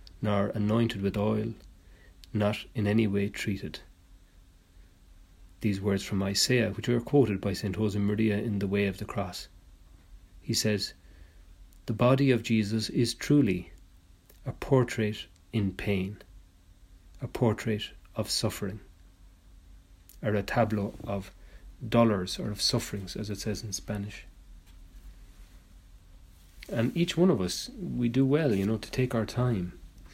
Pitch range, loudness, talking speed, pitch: 90-110 Hz, -29 LUFS, 135 wpm, 100 Hz